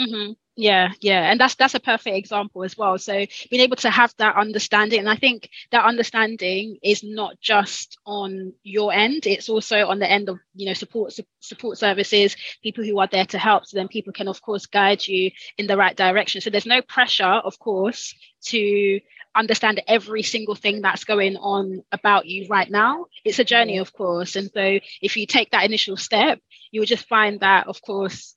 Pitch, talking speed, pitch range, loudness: 205 Hz, 205 wpm, 195-220 Hz, -20 LUFS